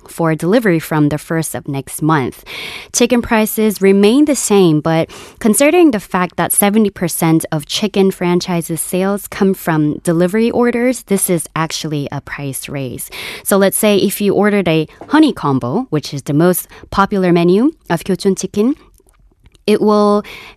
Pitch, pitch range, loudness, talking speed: 185 Hz, 160-210 Hz, -14 LUFS, 155 wpm